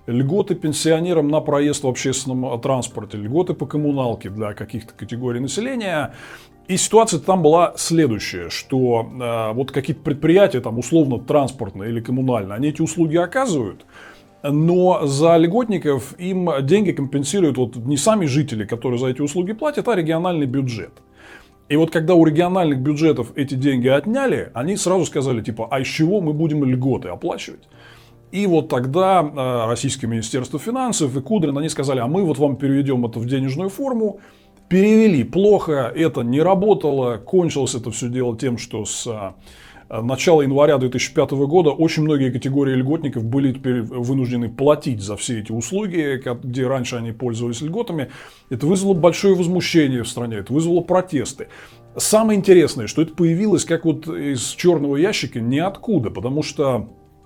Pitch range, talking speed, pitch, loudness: 125-170 Hz, 150 wpm, 140 Hz, -19 LUFS